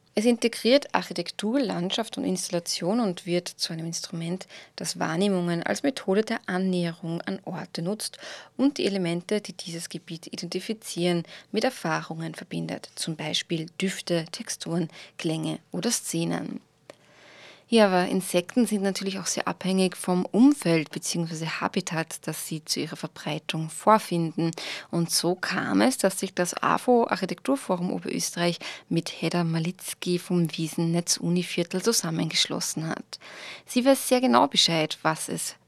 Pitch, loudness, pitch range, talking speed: 180 Hz, -26 LUFS, 165-205 Hz, 135 wpm